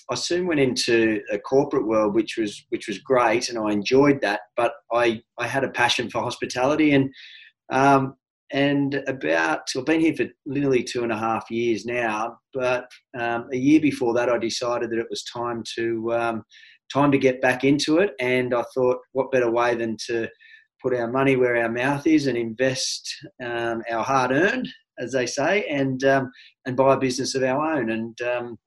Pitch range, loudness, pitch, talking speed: 115-135 Hz, -23 LUFS, 125 Hz, 200 wpm